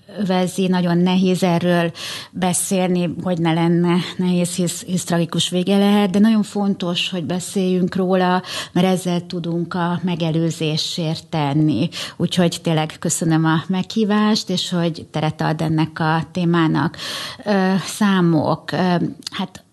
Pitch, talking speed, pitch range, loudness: 175 Hz, 120 wpm, 165-185 Hz, -19 LUFS